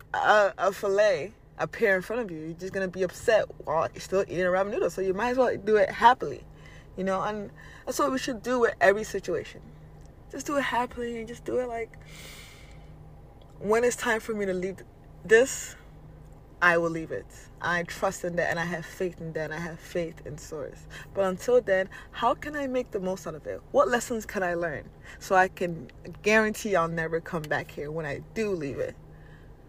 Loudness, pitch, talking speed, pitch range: -27 LUFS, 190 Hz, 215 wpm, 170-225 Hz